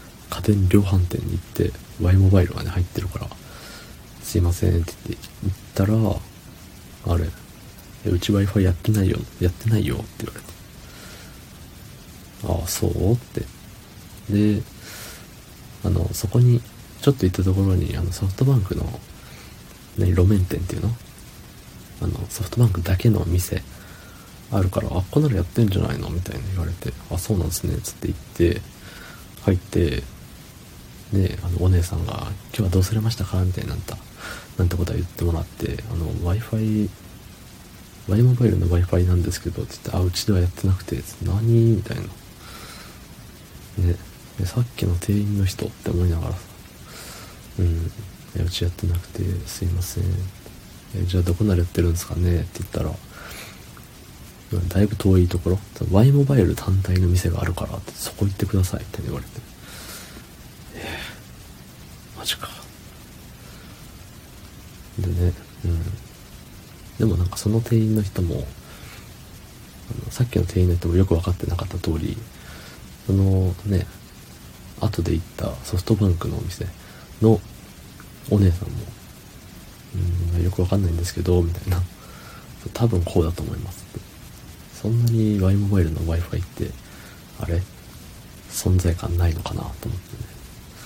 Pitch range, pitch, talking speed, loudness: 90-110 Hz, 95 Hz, 300 characters per minute, -23 LUFS